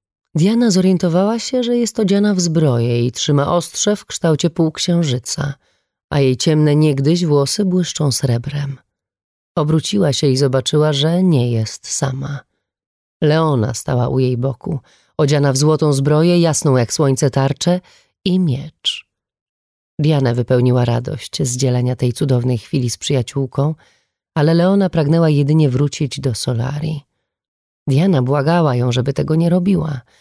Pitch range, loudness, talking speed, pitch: 130-165 Hz, -16 LUFS, 135 wpm, 145 Hz